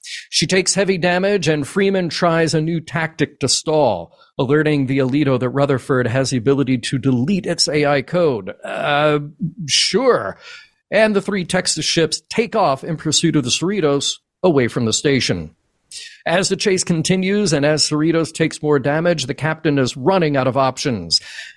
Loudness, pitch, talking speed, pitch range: -17 LUFS, 155 Hz, 165 wpm, 140-175 Hz